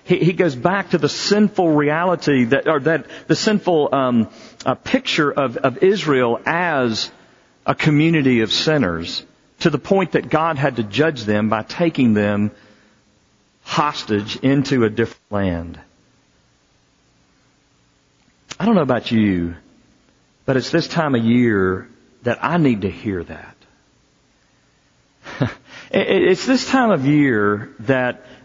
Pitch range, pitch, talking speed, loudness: 110-165 Hz, 135 Hz, 135 wpm, -18 LUFS